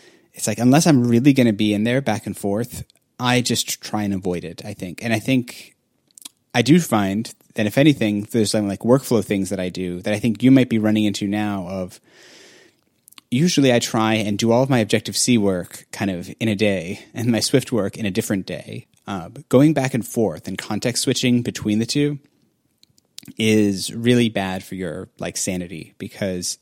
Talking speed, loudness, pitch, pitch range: 205 wpm, -20 LUFS, 110 Hz, 100-125 Hz